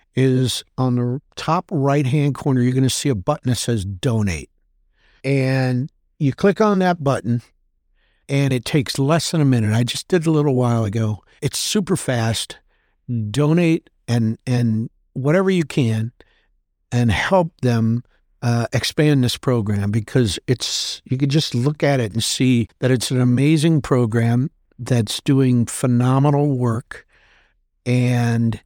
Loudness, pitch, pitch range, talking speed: -19 LUFS, 130 Hz, 120-145 Hz, 155 wpm